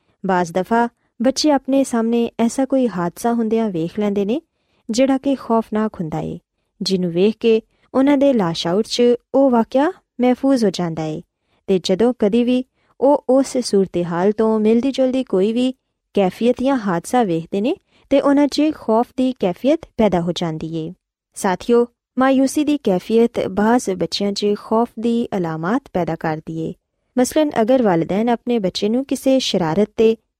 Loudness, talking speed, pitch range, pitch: -18 LUFS, 160 wpm, 190-260 Hz, 230 Hz